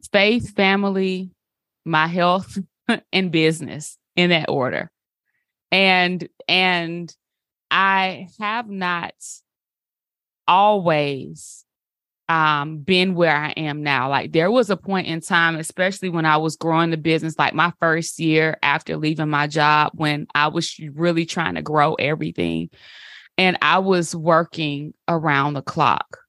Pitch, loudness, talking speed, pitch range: 165 Hz, -19 LUFS, 130 wpm, 155-185 Hz